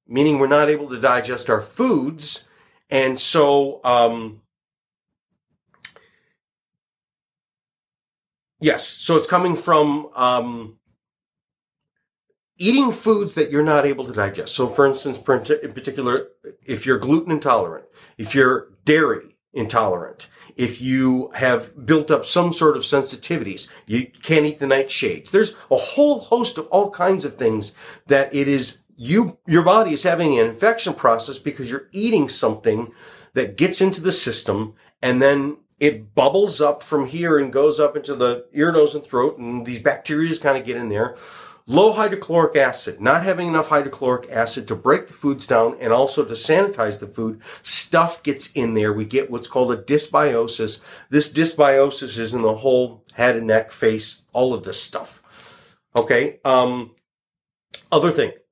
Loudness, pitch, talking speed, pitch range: -19 LUFS, 140 Hz, 155 wpm, 125-160 Hz